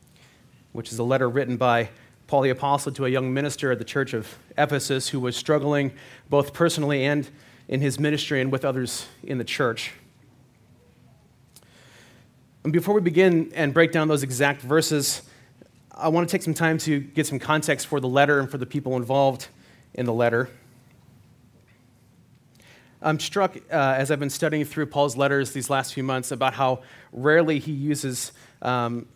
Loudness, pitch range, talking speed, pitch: -24 LUFS, 125-145 Hz, 175 wpm, 135 Hz